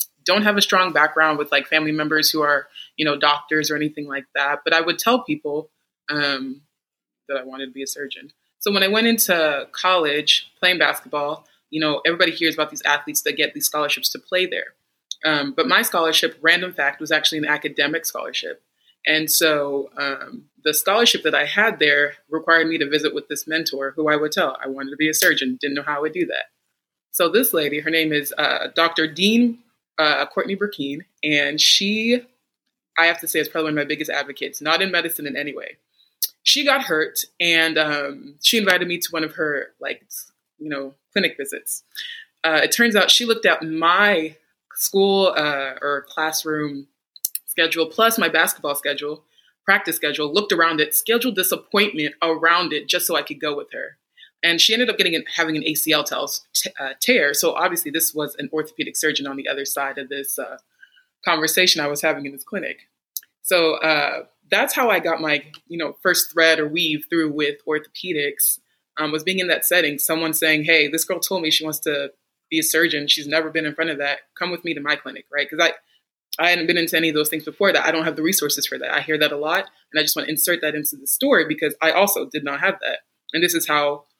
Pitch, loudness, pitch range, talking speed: 155 Hz, -19 LUFS, 150-175 Hz, 215 wpm